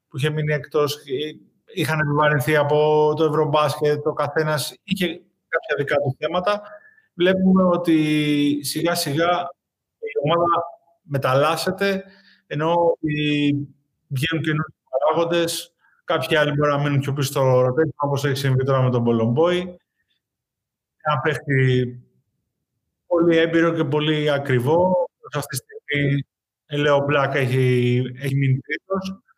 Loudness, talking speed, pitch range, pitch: -21 LUFS, 125 wpm, 140-170 Hz, 150 Hz